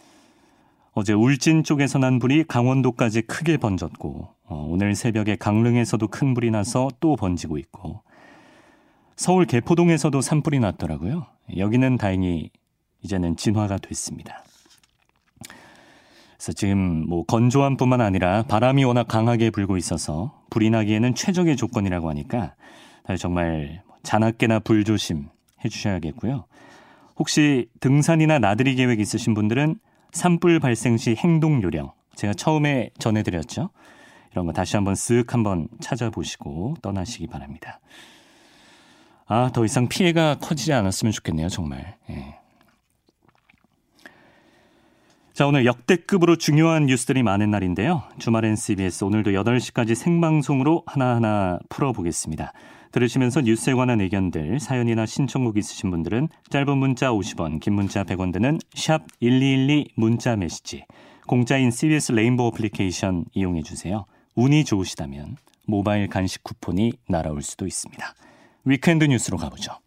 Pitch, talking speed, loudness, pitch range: 115 Hz, 310 characters per minute, -22 LUFS, 100-140 Hz